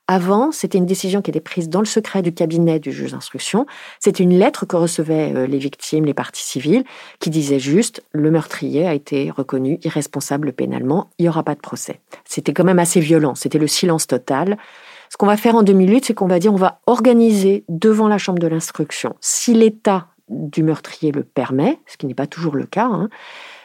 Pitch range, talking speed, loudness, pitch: 150-205 Hz, 210 wpm, -17 LUFS, 175 Hz